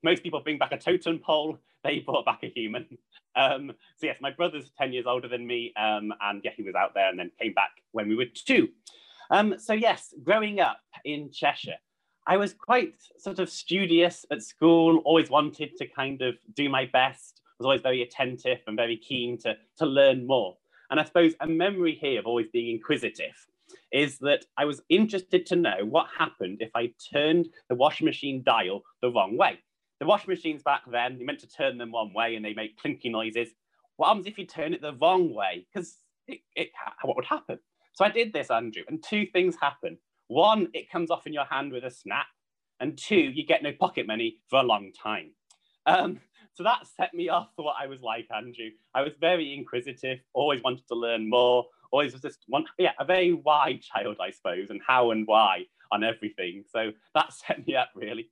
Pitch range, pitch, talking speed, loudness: 125-180 Hz, 150 Hz, 215 wpm, -27 LUFS